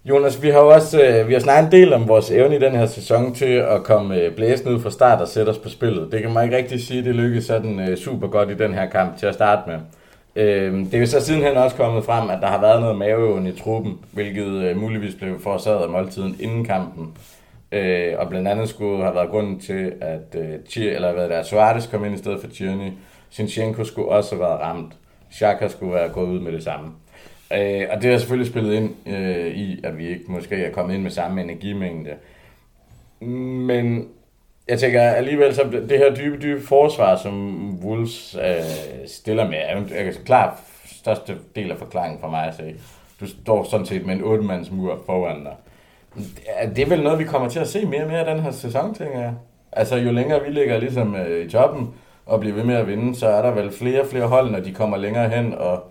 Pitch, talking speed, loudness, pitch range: 110 Hz, 220 wpm, -19 LUFS, 95-125 Hz